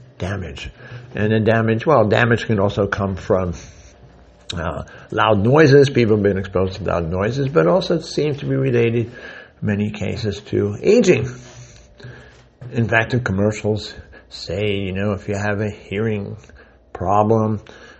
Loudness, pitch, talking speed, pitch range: -18 LUFS, 110 Hz, 145 wpm, 100-120 Hz